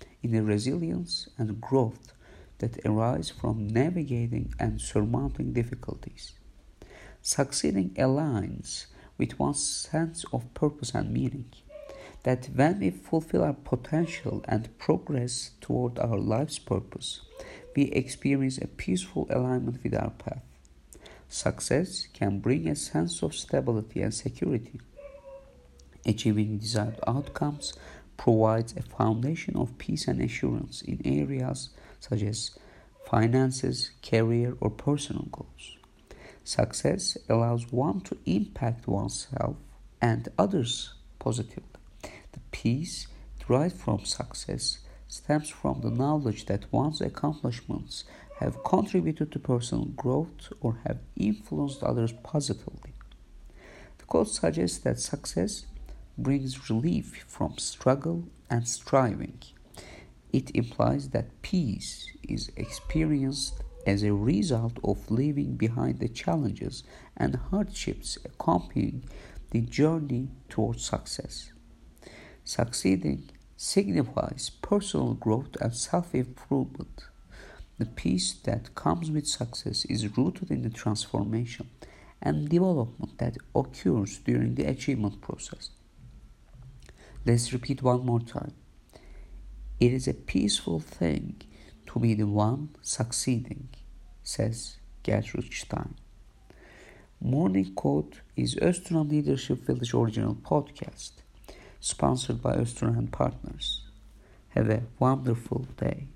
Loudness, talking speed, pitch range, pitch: -29 LUFS, 110 wpm, 105-135 Hz, 120 Hz